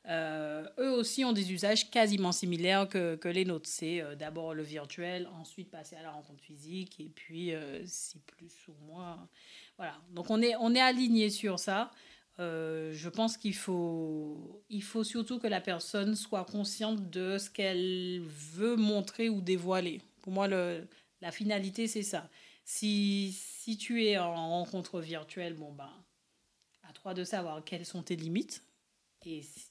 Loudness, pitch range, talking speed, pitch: -34 LUFS, 165-210 Hz, 170 wpm, 185 Hz